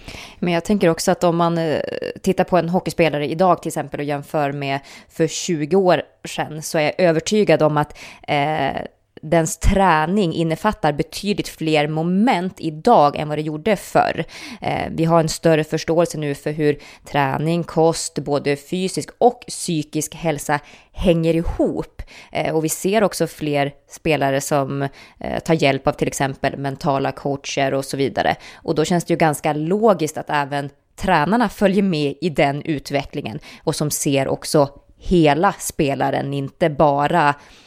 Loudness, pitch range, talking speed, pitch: -19 LUFS, 145-170 Hz, 160 wpm, 160 Hz